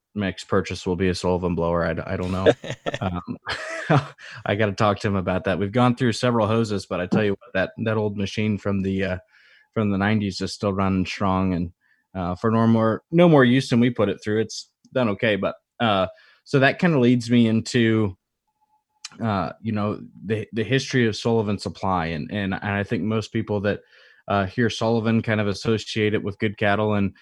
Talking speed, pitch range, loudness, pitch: 215 wpm, 95-115 Hz, -23 LUFS, 105 Hz